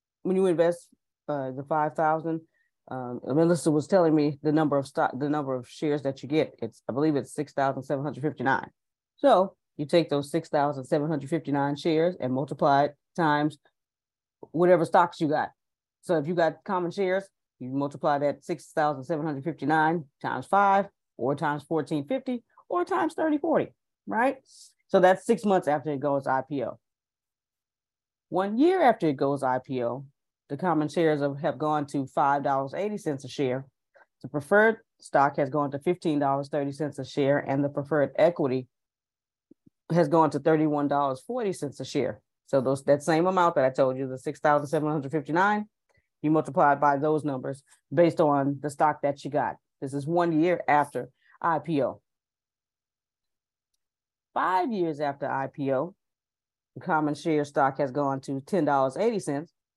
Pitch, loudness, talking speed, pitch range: 150 Hz, -26 LUFS, 160 wpm, 140-170 Hz